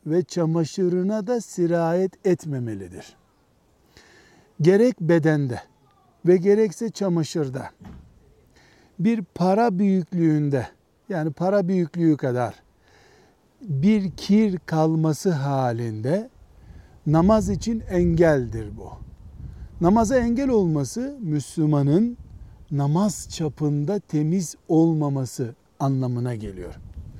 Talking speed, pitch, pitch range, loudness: 75 wpm, 165 Hz, 140-190 Hz, -22 LUFS